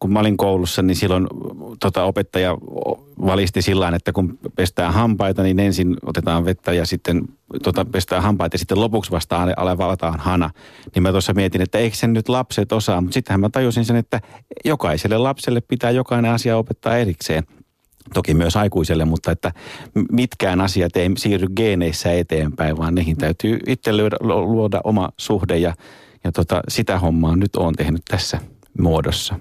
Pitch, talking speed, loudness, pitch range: 95 Hz, 165 wpm, -19 LUFS, 90-110 Hz